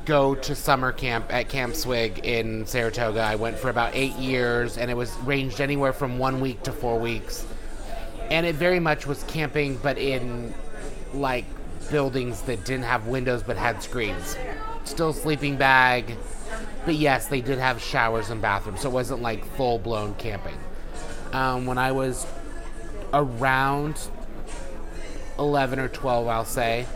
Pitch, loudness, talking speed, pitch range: 130 Hz, -25 LUFS, 155 wpm, 115-135 Hz